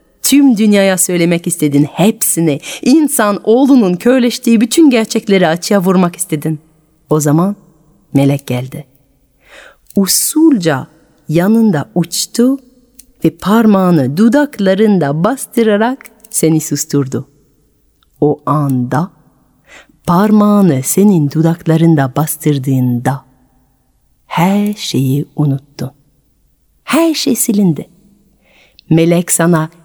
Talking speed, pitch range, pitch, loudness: 80 wpm, 150-215 Hz, 175 Hz, -12 LUFS